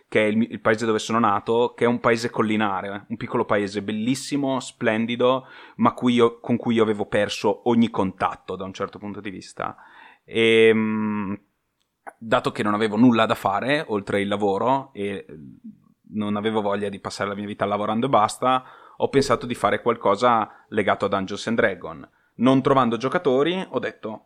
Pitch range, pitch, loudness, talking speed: 105-125 Hz, 110 Hz, -22 LUFS, 175 wpm